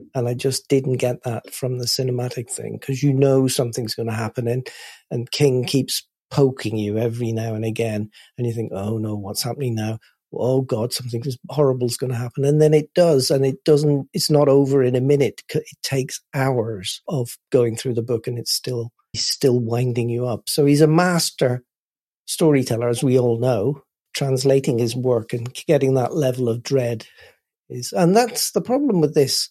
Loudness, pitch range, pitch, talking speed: -20 LUFS, 120-140 Hz, 130 Hz, 195 wpm